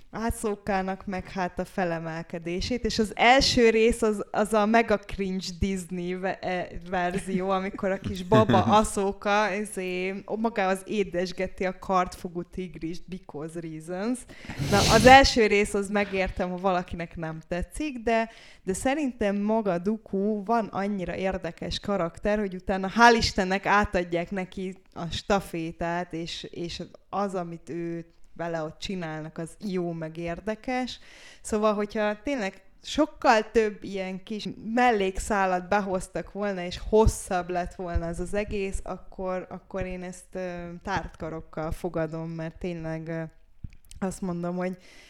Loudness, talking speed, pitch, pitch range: -27 LUFS, 130 wpm, 190 Hz, 175-210 Hz